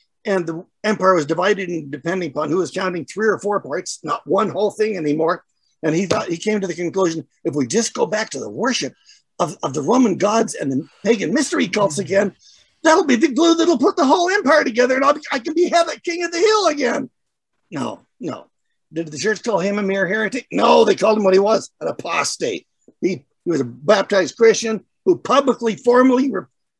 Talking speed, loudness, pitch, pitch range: 220 wpm, -18 LUFS, 215 Hz, 190-280 Hz